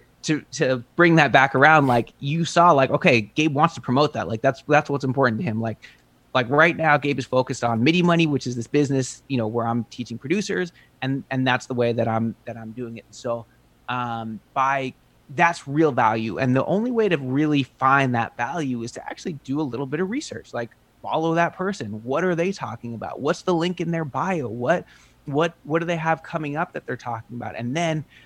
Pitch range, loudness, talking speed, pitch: 120-160 Hz, -22 LUFS, 225 wpm, 135 Hz